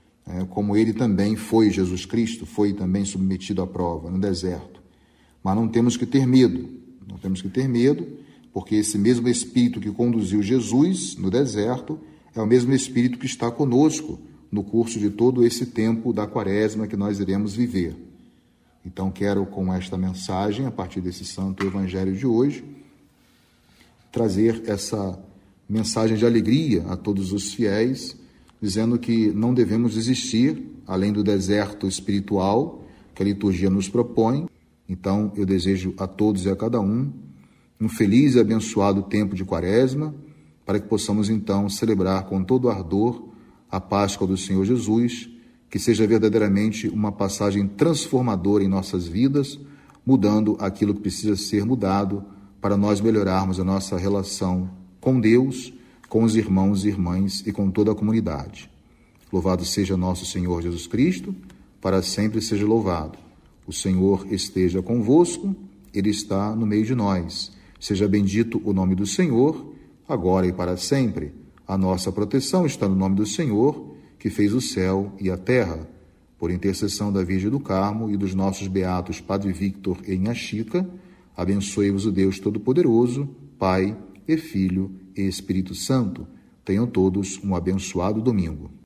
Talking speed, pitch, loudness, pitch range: 150 wpm, 100 Hz, -22 LUFS, 95-115 Hz